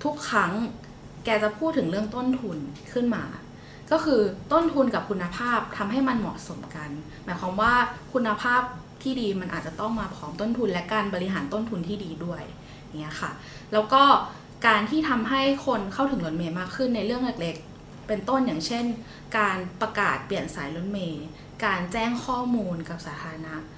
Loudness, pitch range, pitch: -26 LUFS, 175-245 Hz, 210 Hz